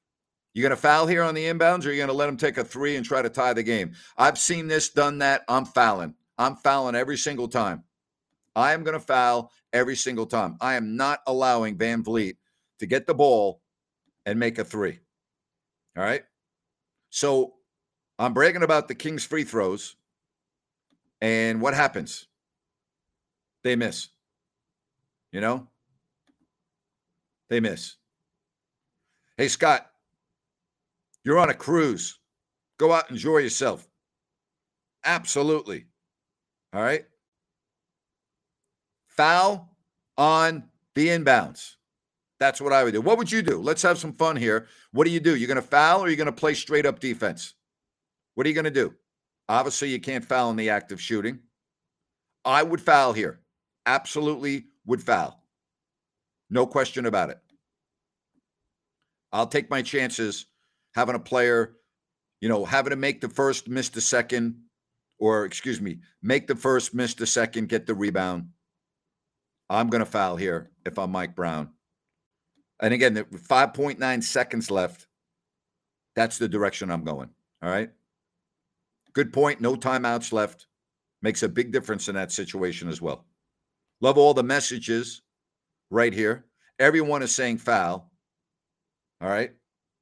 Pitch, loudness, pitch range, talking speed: 130 Hz, -24 LUFS, 115-145 Hz, 150 wpm